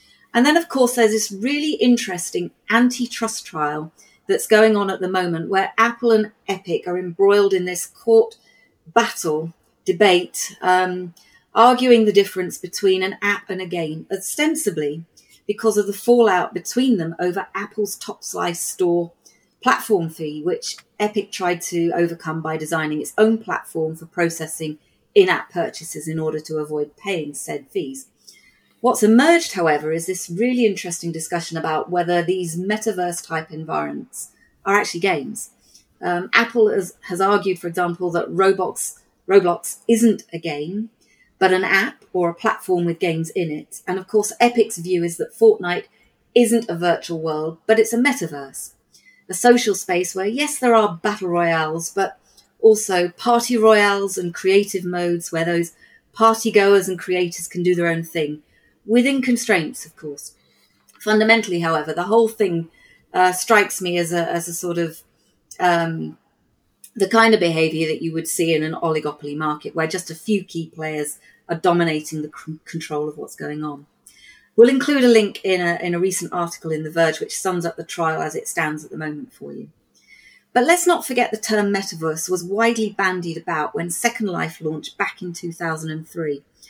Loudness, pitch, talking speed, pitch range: -20 LUFS, 180 Hz, 170 wpm, 165-215 Hz